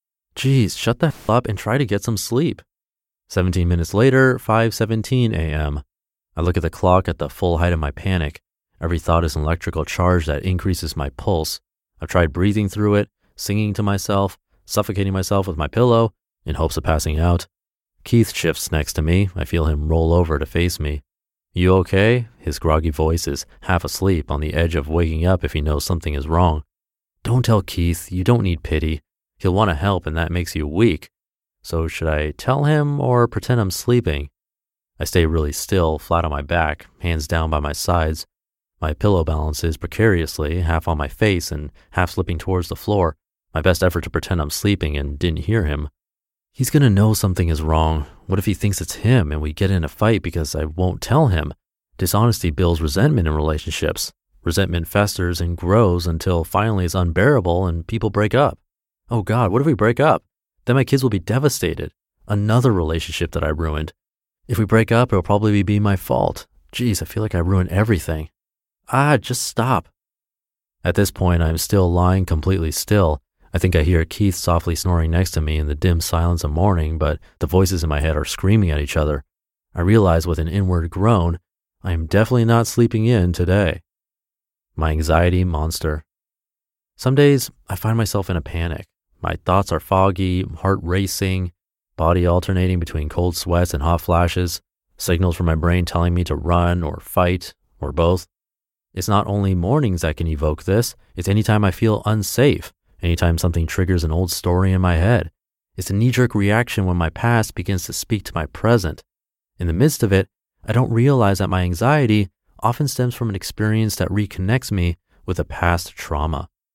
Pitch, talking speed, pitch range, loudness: 90 Hz, 195 wpm, 80-105 Hz, -19 LUFS